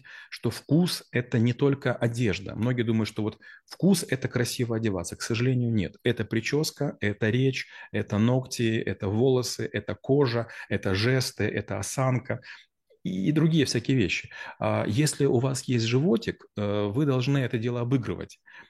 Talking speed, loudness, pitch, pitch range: 145 wpm, -27 LUFS, 120 Hz, 105-130 Hz